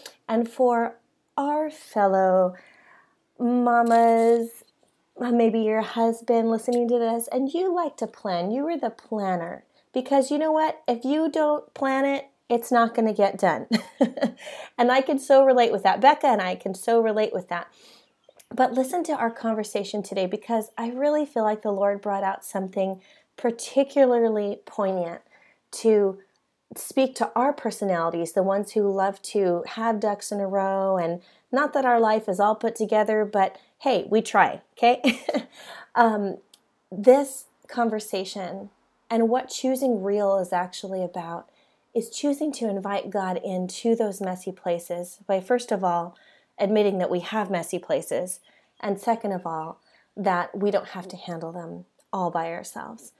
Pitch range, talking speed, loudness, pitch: 195-250 Hz, 160 wpm, -24 LUFS, 220 Hz